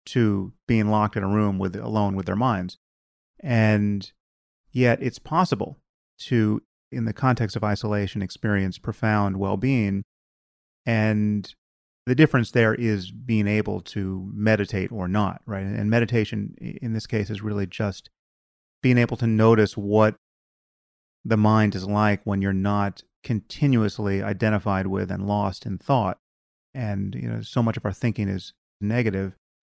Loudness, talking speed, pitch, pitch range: -24 LUFS, 150 wpm, 105 Hz, 95-110 Hz